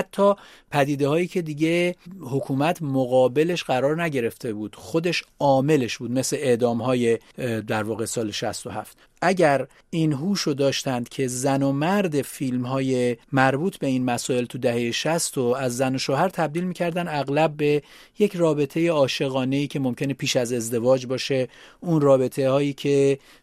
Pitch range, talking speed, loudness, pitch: 125-160 Hz, 155 wpm, -23 LUFS, 140 Hz